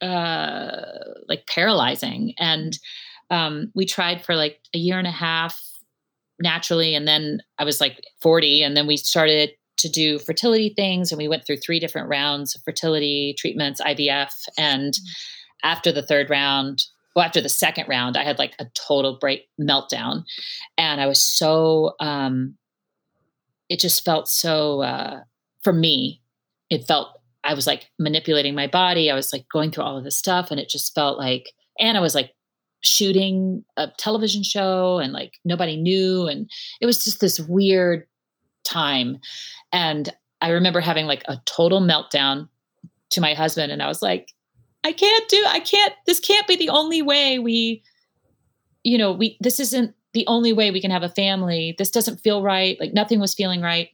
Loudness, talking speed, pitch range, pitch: -20 LUFS, 175 wpm, 145-195 Hz, 165 Hz